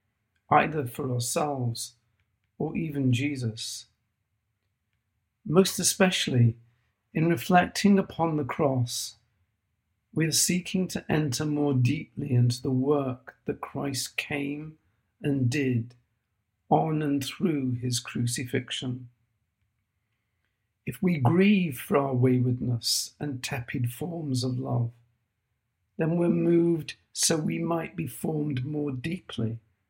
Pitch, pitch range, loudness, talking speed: 125 Hz, 115-150 Hz, -27 LUFS, 110 wpm